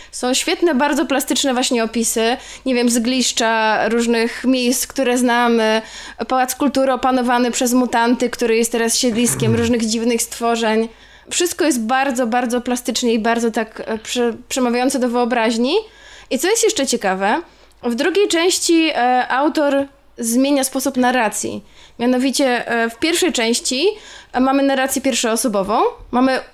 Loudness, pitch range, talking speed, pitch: -17 LUFS, 235-275 Hz, 130 wpm, 250 Hz